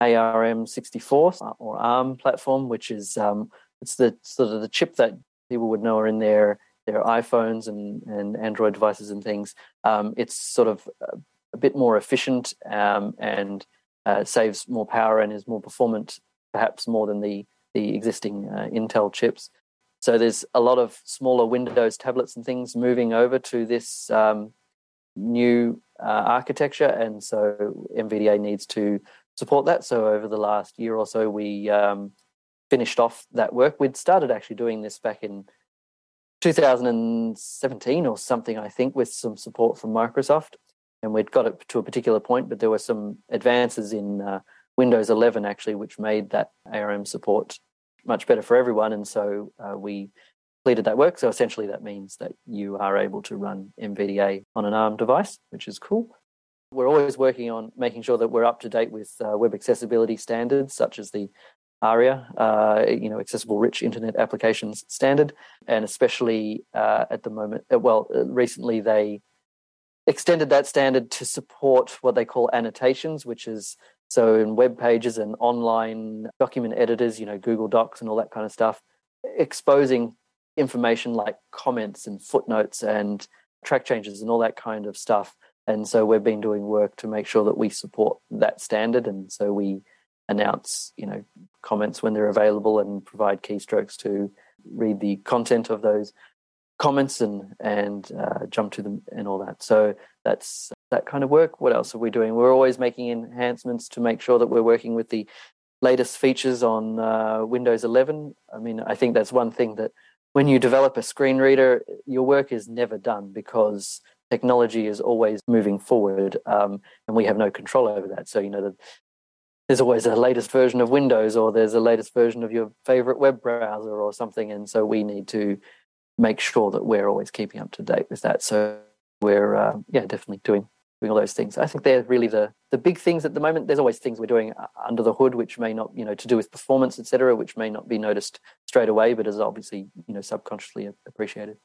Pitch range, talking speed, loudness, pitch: 105-125 Hz, 190 wpm, -23 LUFS, 115 Hz